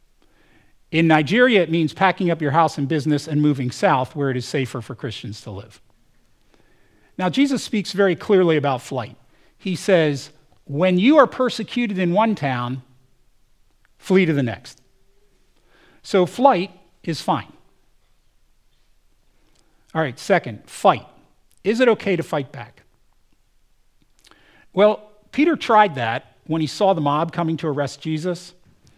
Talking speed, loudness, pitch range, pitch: 140 wpm, -20 LUFS, 135-195 Hz, 160 Hz